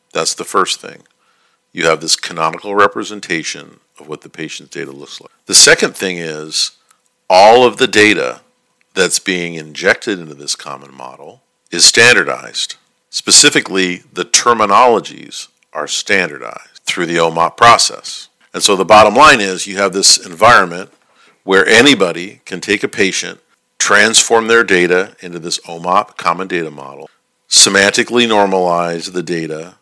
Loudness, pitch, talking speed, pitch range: -11 LUFS, 90 Hz, 145 wpm, 80-100 Hz